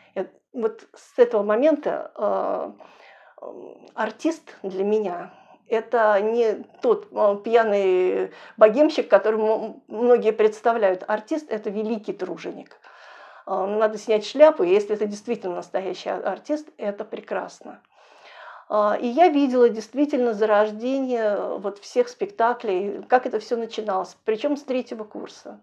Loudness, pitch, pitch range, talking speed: -22 LUFS, 220 Hz, 210-265 Hz, 110 wpm